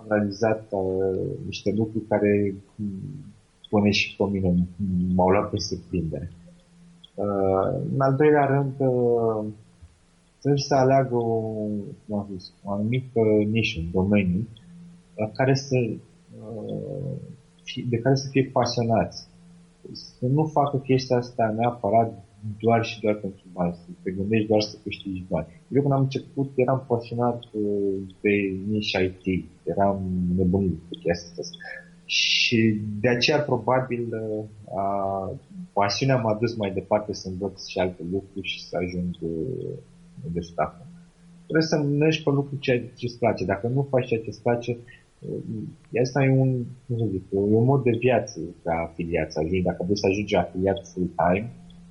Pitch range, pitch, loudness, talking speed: 95-130 Hz, 105 Hz, -25 LUFS, 140 wpm